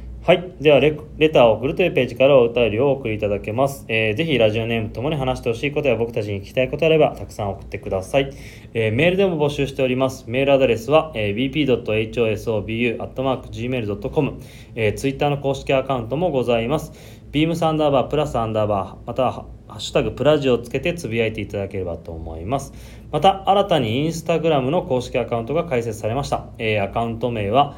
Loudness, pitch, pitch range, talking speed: -20 LUFS, 130 Hz, 110-145 Hz, 510 characters per minute